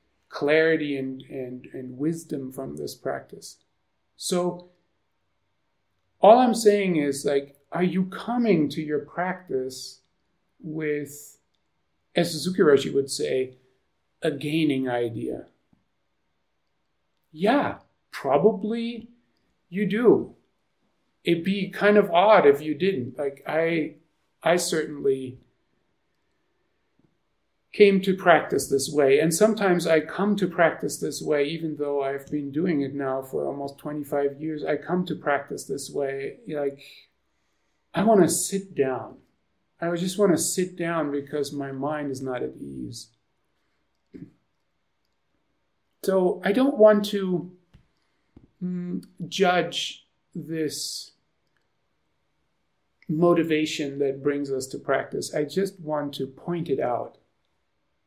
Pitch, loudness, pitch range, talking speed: 155 Hz, -24 LUFS, 140-180 Hz, 120 wpm